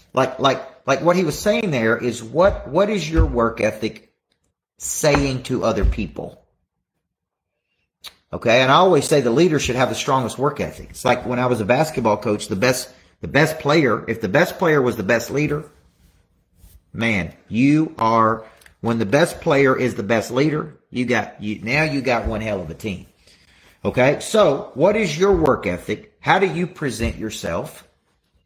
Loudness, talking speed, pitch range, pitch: -19 LUFS, 185 wpm, 105-145 Hz, 120 Hz